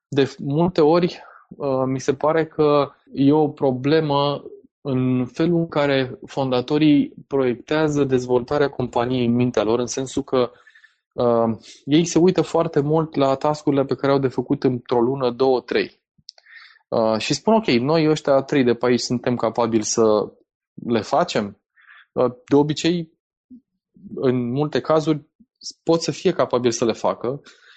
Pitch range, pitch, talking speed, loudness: 125-155 Hz, 140 Hz, 155 wpm, -20 LUFS